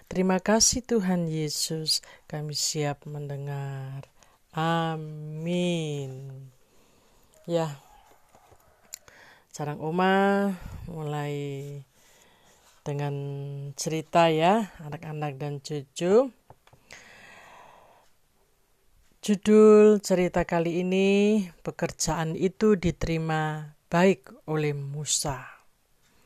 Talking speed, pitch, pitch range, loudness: 65 wpm, 160 Hz, 145-185 Hz, -26 LUFS